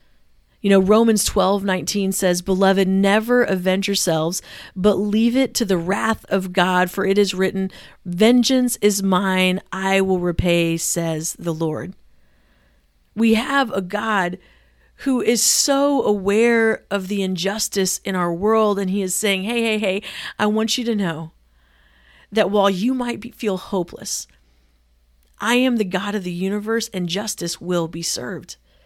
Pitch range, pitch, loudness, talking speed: 175-215 Hz, 195 Hz, -19 LUFS, 160 wpm